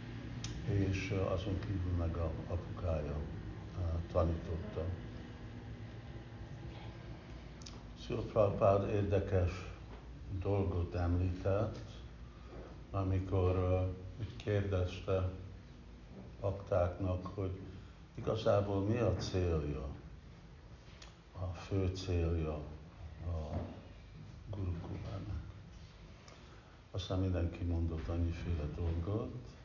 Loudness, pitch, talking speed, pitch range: -38 LUFS, 95 Hz, 65 wpm, 85-100 Hz